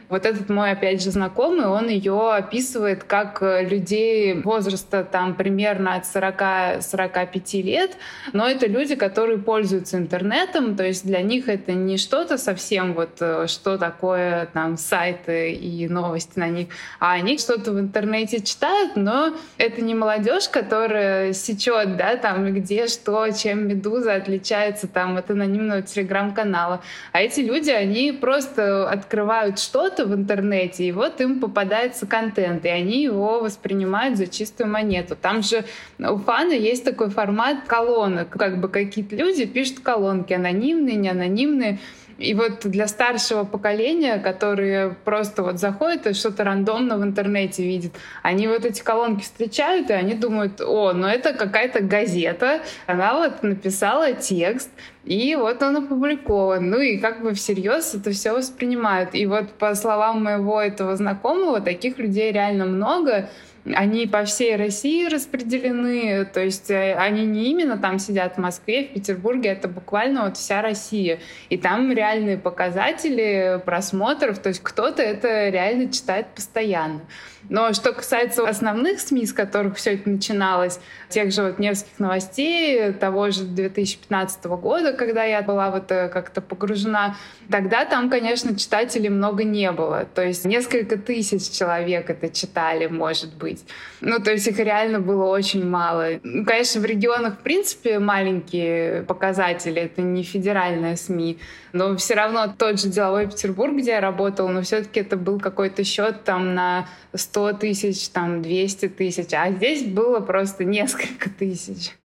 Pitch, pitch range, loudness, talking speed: 205 Hz, 190-225 Hz, -22 LUFS, 150 wpm